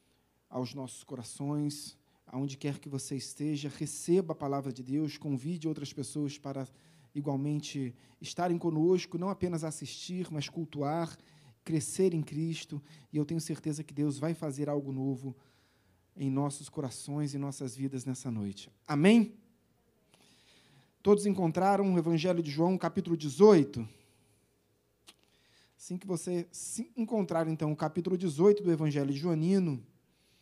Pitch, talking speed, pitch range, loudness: 150 Hz, 135 wpm, 135-170 Hz, -32 LUFS